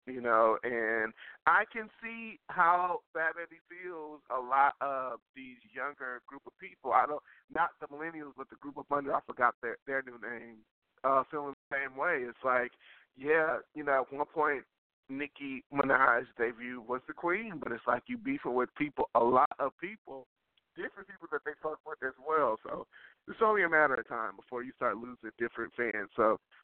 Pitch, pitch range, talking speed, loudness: 140 Hz, 125-165 Hz, 190 wpm, -32 LUFS